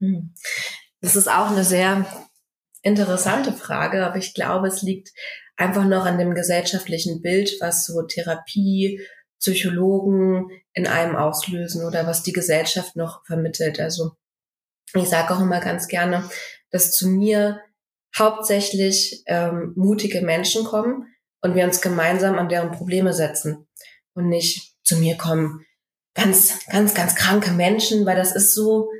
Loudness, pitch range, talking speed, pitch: -20 LUFS, 170-195 Hz, 140 wpm, 185 Hz